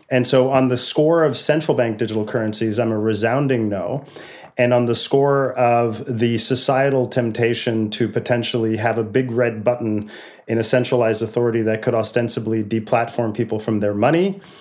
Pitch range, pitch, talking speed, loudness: 110-130 Hz, 120 Hz, 170 wpm, -19 LUFS